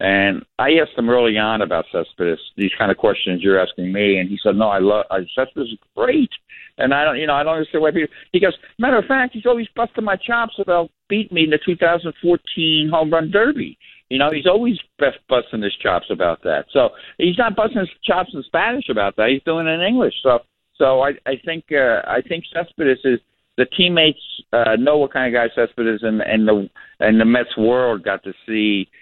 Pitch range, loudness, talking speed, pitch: 115-180 Hz, -18 LUFS, 225 wpm, 155 Hz